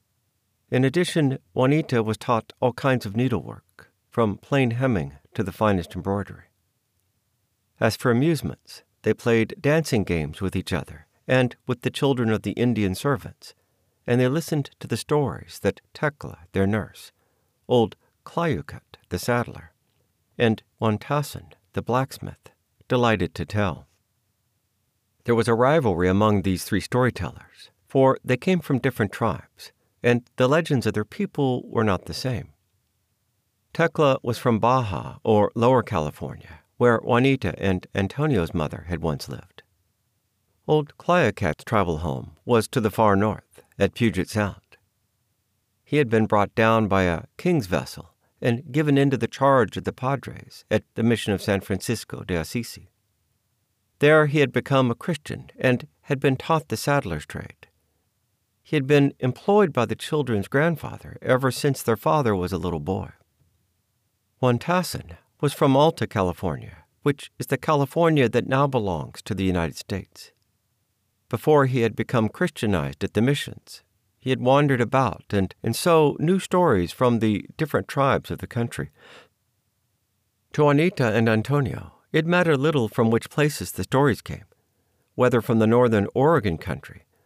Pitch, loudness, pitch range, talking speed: 115 Hz, -23 LUFS, 100-135 Hz, 150 wpm